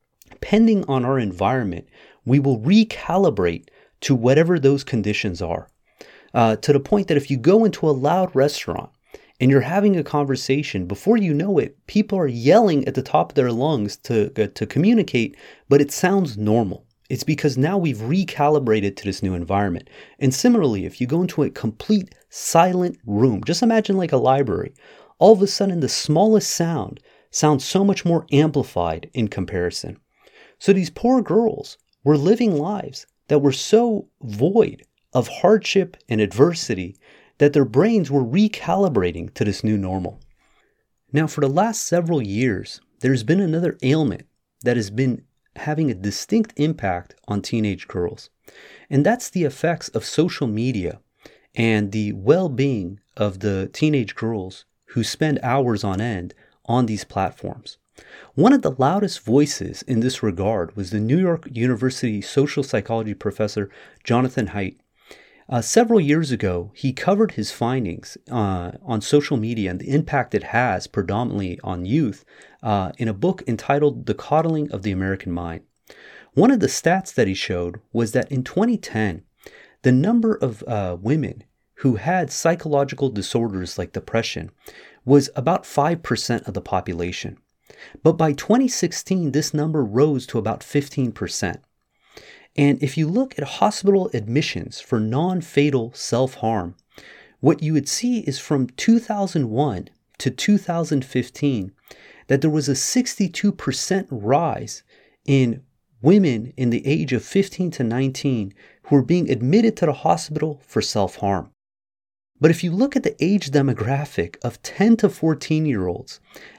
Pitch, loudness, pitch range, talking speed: 135 Hz, -20 LUFS, 110-165 Hz, 155 wpm